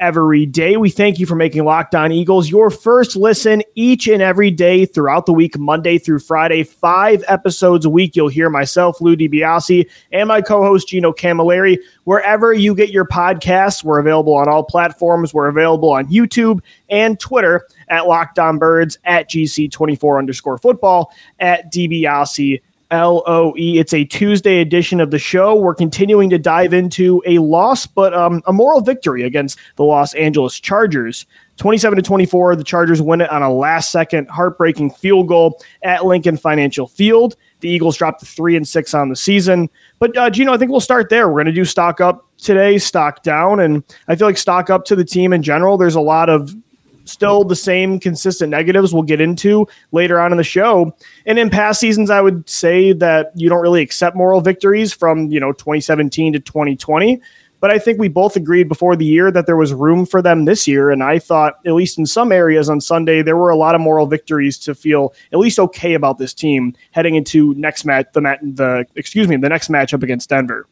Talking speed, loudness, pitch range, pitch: 200 wpm, -13 LUFS, 155-190 Hz, 170 Hz